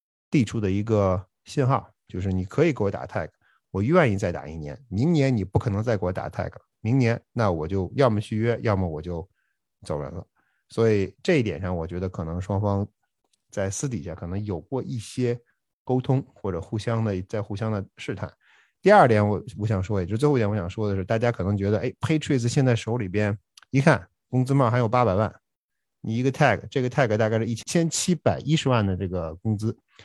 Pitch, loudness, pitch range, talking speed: 110 Hz, -25 LUFS, 95-125 Hz, 330 characters per minute